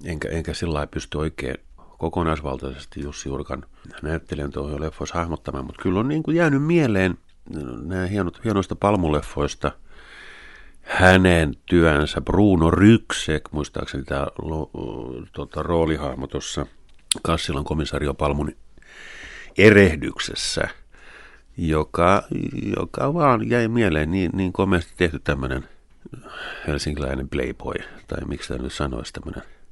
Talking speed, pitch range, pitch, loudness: 110 wpm, 75-95 Hz, 80 Hz, -22 LUFS